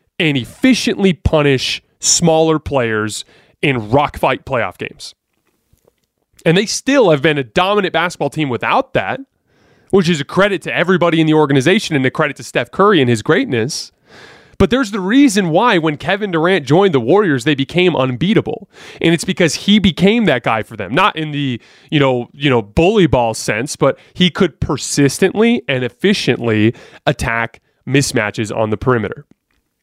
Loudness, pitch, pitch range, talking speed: -14 LUFS, 155 Hz, 135-190 Hz, 165 wpm